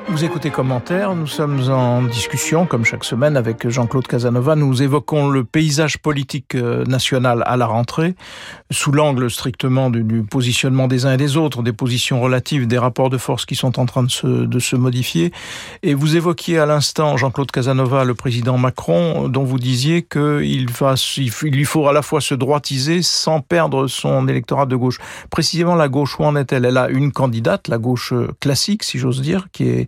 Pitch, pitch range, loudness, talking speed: 135 Hz, 125-150 Hz, -17 LUFS, 190 wpm